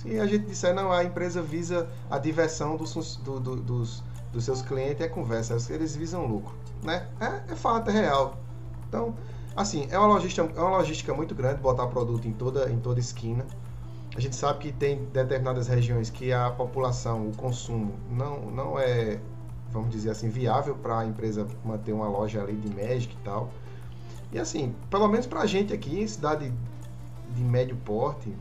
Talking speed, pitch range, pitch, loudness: 180 wpm, 115-140 Hz, 125 Hz, -29 LUFS